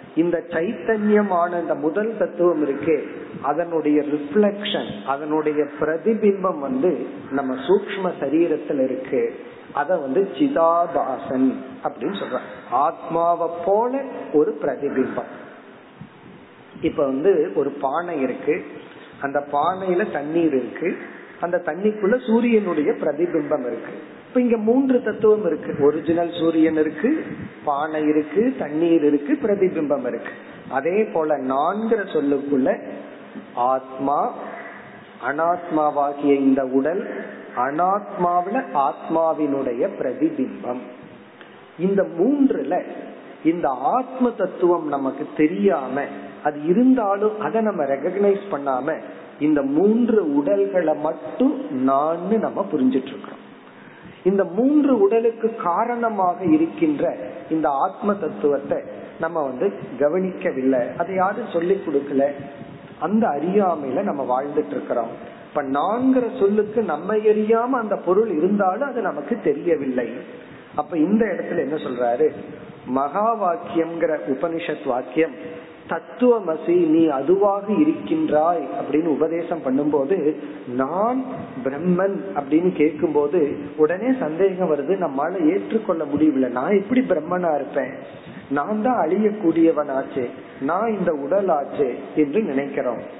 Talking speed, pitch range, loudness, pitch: 95 wpm, 150-215 Hz, -21 LUFS, 170 Hz